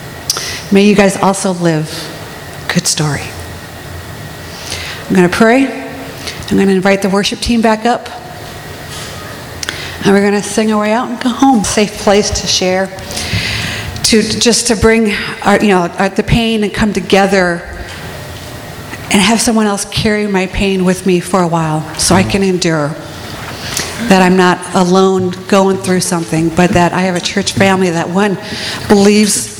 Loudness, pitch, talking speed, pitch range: -12 LUFS, 195 Hz, 155 wpm, 175-210 Hz